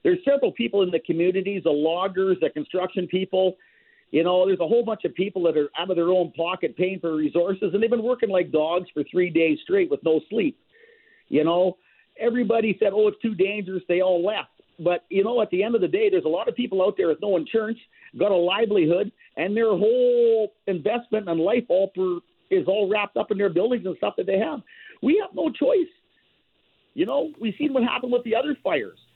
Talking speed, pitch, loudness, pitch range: 225 wpm, 200 Hz, -23 LUFS, 180-250 Hz